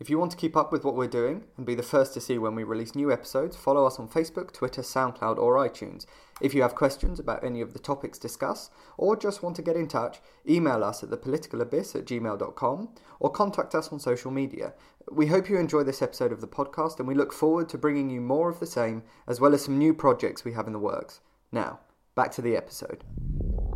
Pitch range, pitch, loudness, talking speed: 120-155 Hz, 140 Hz, -28 LUFS, 235 wpm